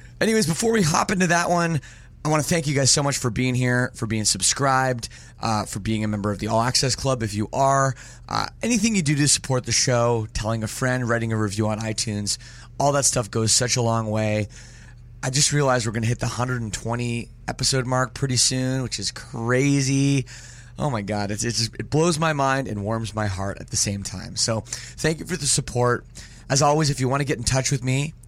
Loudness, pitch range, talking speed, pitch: -22 LUFS, 115-140 Hz, 230 wpm, 125 Hz